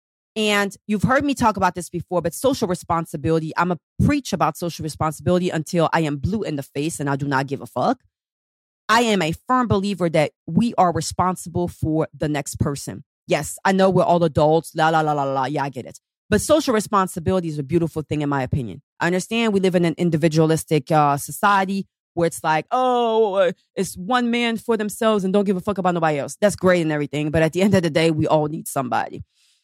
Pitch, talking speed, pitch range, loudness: 170 Hz, 220 wpm, 155-195 Hz, -21 LUFS